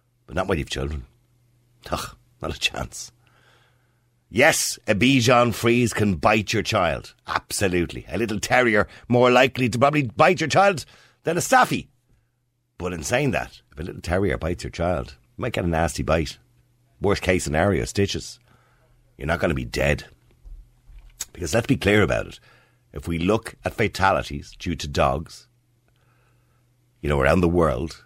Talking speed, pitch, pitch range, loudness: 165 wpm, 115 Hz, 85-125 Hz, -22 LUFS